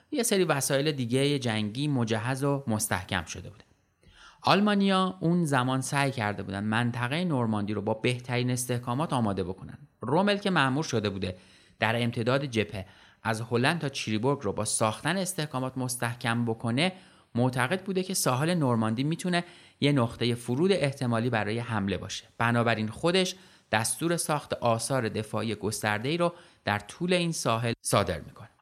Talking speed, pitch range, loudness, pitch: 145 wpm, 110-150 Hz, -28 LUFS, 125 Hz